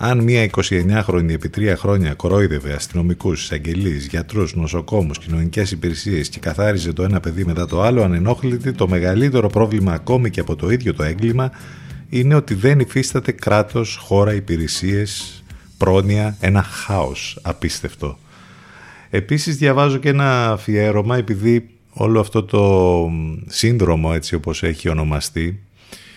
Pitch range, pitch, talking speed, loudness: 85-115 Hz, 100 Hz, 130 wpm, -18 LUFS